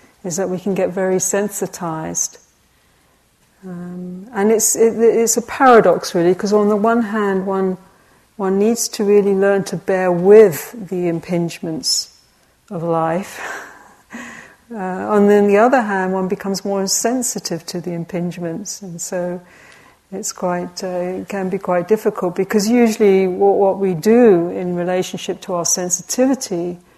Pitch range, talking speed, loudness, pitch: 180-210 Hz, 150 wpm, -17 LUFS, 190 Hz